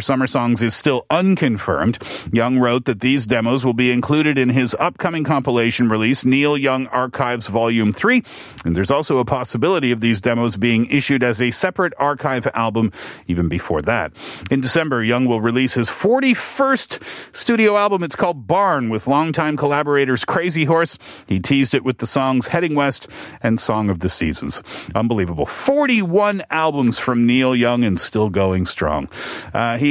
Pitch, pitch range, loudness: 130 Hz, 115-150 Hz, -18 LUFS